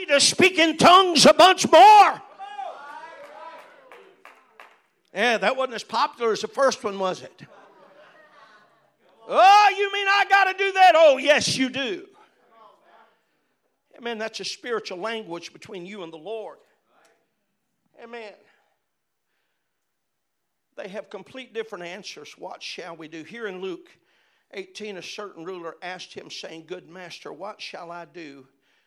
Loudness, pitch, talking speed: -18 LUFS, 225 Hz, 140 wpm